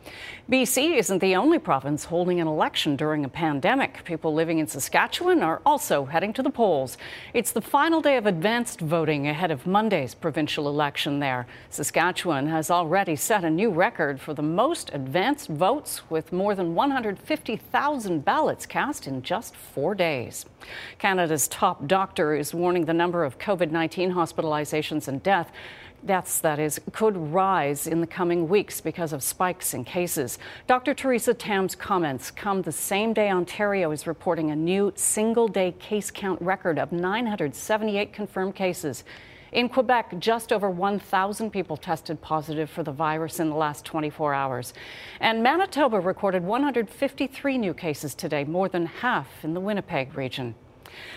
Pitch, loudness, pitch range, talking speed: 175 Hz, -25 LUFS, 155-210 Hz, 155 wpm